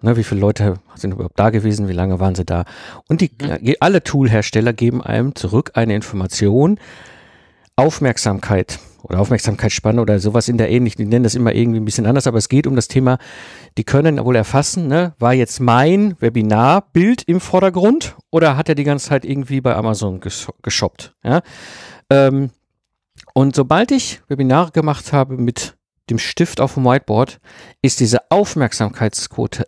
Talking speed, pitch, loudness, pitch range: 170 wpm, 120 Hz, -16 LUFS, 110-140 Hz